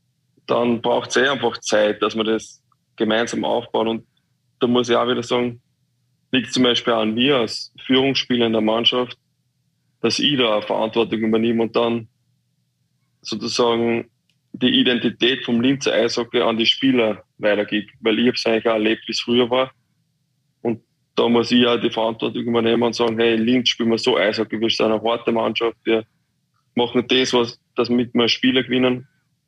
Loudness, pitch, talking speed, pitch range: -19 LUFS, 120 Hz, 185 wpm, 115-125 Hz